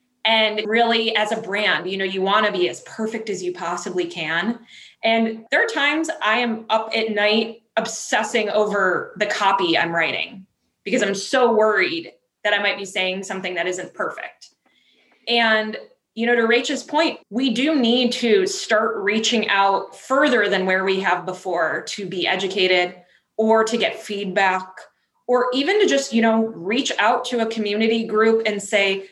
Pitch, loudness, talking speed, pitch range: 220 Hz, -20 LUFS, 175 wpm, 195-235 Hz